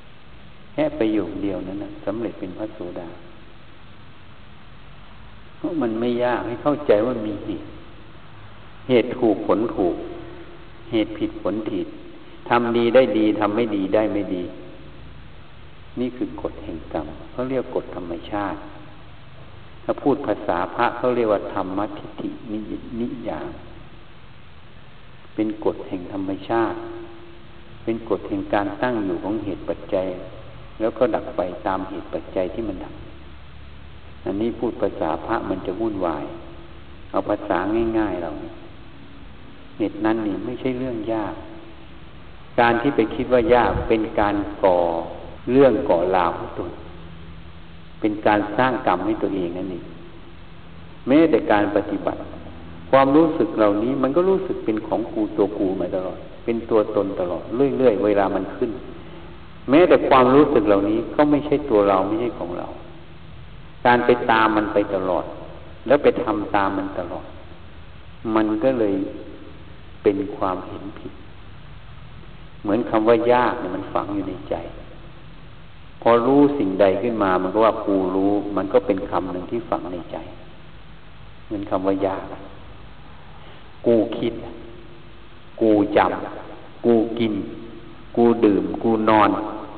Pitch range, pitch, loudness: 95-120 Hz, 110 Hz, -21 LUFS